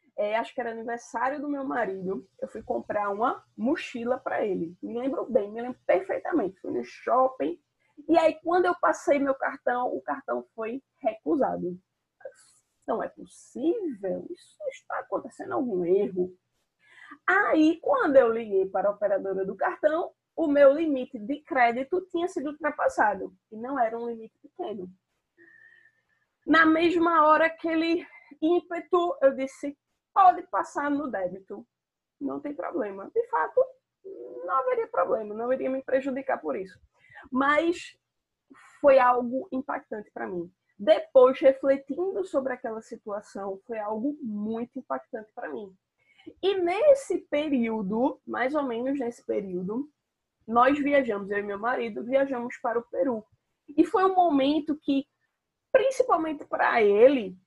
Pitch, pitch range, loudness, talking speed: 270 Hz, 230-325 Hz, -26 LUFS, 140 wpm